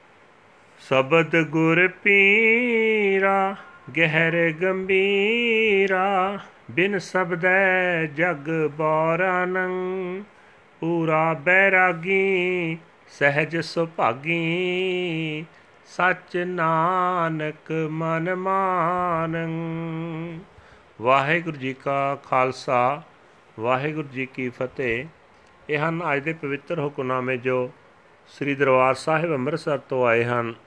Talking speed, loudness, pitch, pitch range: 70 wpm, -22 LUFS, 165 Hz, 150-185 Hz